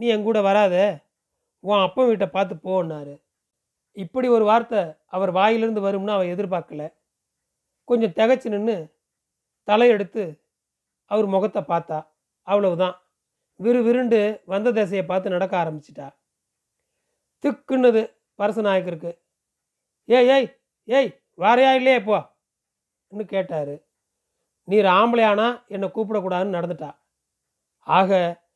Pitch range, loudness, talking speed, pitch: 185-230 Hz, -21 LUFS, 100 wpm, 205 Hz